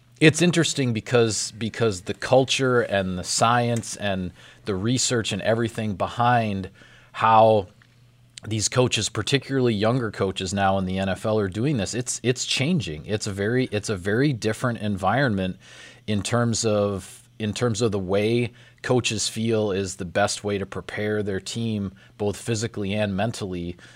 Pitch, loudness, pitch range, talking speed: 110 Hz, -23 LUFS, 100-120 Hz, 155 wpm